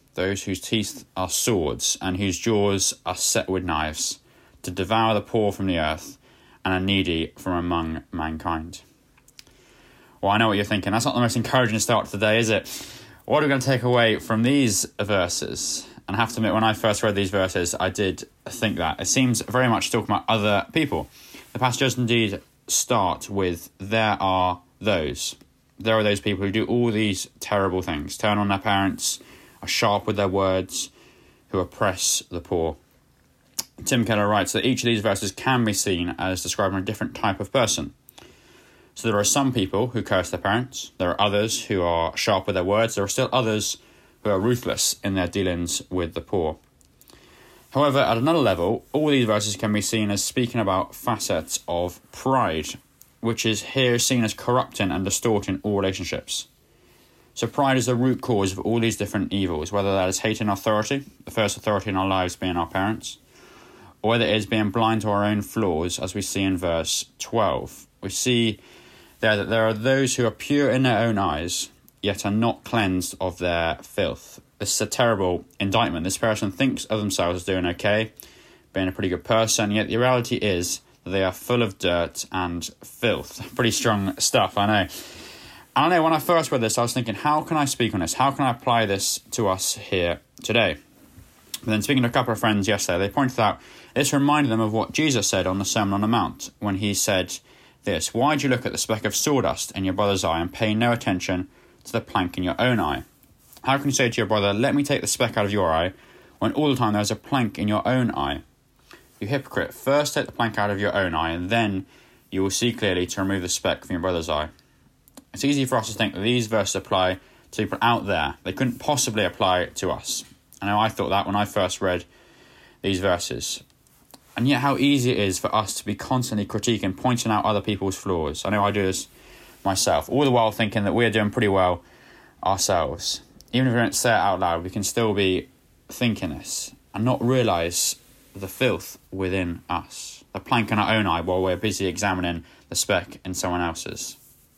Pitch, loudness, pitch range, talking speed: 105 Hz, -23 LUFS, 95-115 Hz, 210 wpm